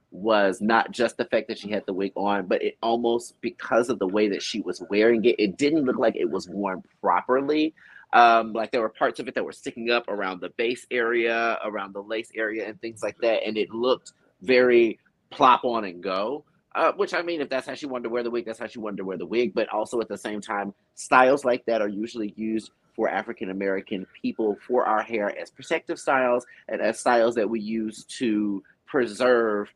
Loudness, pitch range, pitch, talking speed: -25 LUFS, 105-120 Hz, 115 Hz, 230 wpm